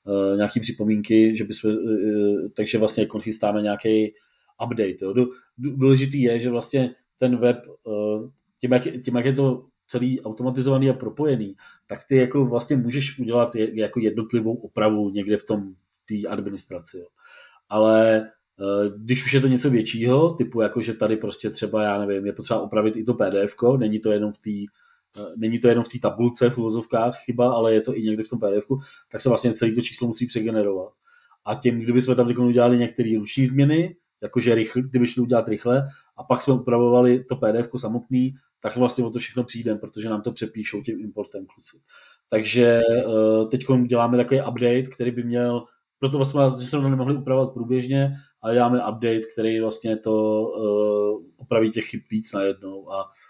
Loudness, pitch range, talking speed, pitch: -22 LUFS, 110-125 Hz, 180 wpm, 120 Hz